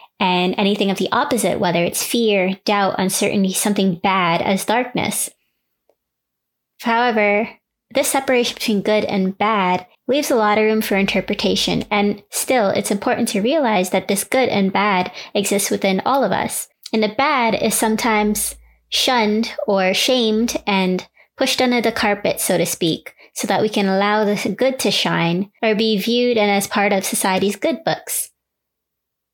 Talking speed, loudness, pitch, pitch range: 160 wpm, -18 LUFS, 210 Hz, 195-230 Hz